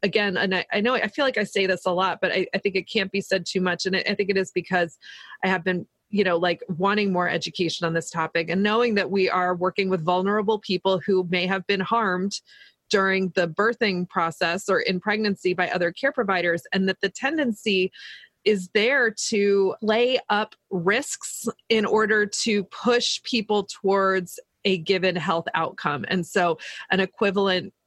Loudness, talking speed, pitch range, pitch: -23 LUFS, 190 wpm, 180-210 Hz, 195 Hz